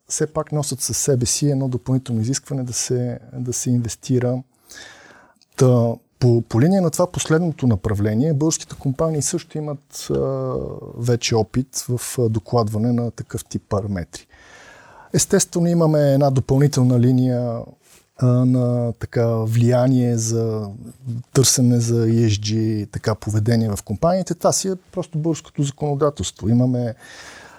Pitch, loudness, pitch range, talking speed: 125 Hz, -20 LUFS, 115-145 Hz, 130 wpm